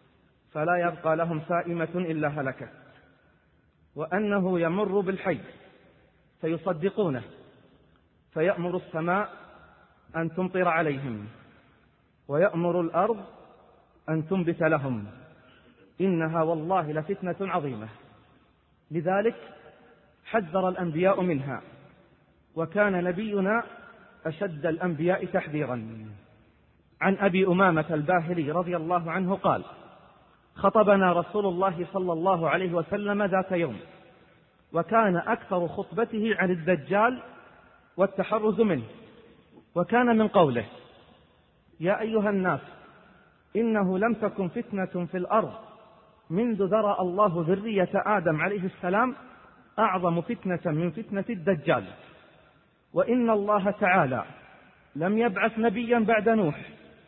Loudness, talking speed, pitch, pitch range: -27 LUFS, 95 wpm, 185 Hz, 165-205 Hz